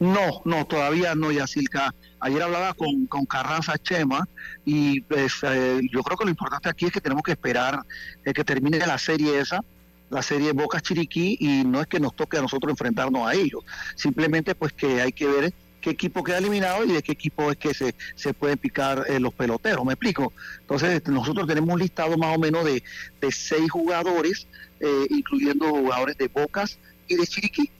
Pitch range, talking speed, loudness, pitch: 140-175 Hz, 195 wpm, -24 LUFS, 155 Hz